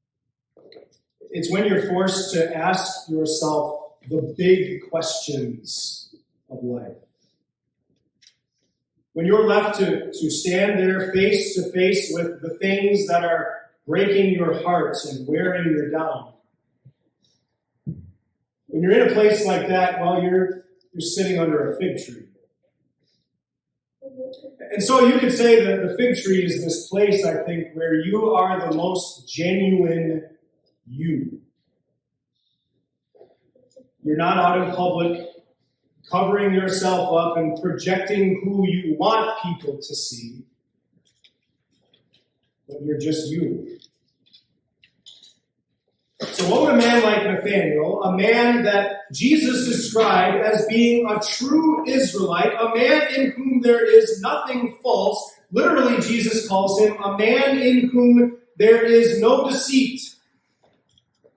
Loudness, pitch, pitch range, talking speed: -20 LUFS, 190 Hz, 165-230 Hz, 125 wpm